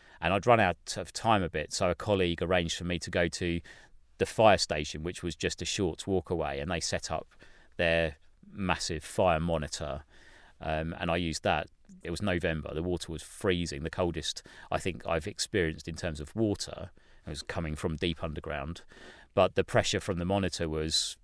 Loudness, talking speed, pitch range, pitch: -31 LUFS, 200 wpm, 80-90 Hz, 85 Hz